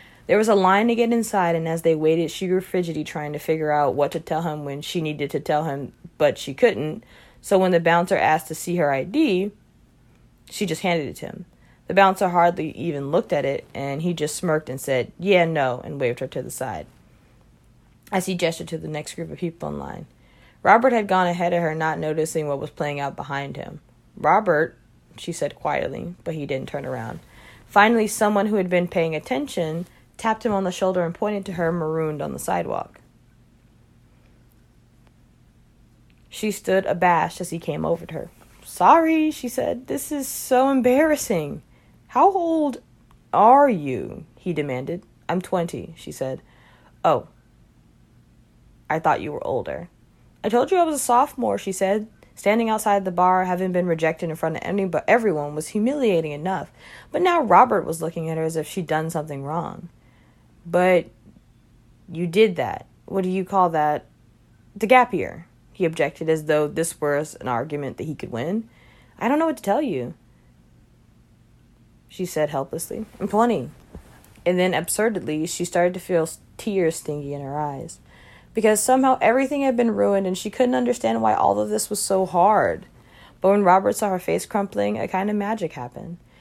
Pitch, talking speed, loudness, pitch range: 175 Hz, 185 wpm, -22 LUFS, 155-210 Hz